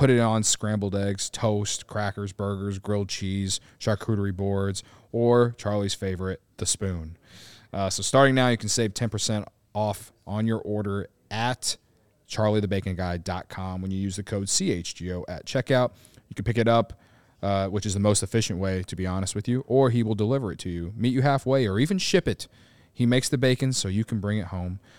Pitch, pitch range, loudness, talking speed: 105 Hz, 100-120 Hz, -26 LUFS, 190 wpm